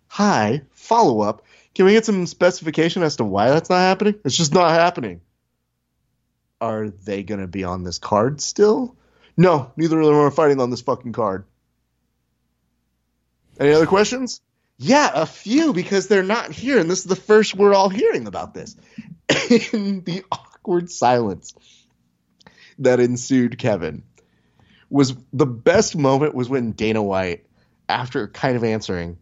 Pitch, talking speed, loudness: 150 Hz, 155 wpm, -19 LUFS